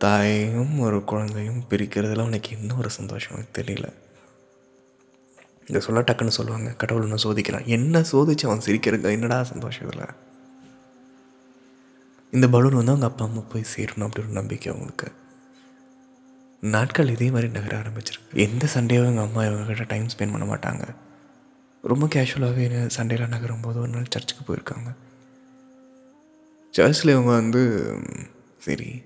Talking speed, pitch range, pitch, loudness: 130 wpm, 110-130 Hz, 120 Hz, -23 LUFS